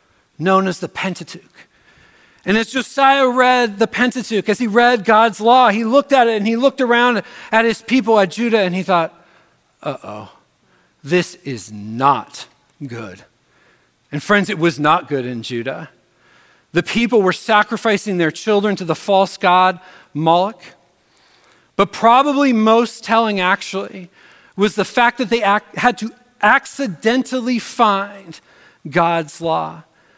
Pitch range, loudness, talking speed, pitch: 175-235 Hz, -16 LUFS, 145 wpm, 210 Hz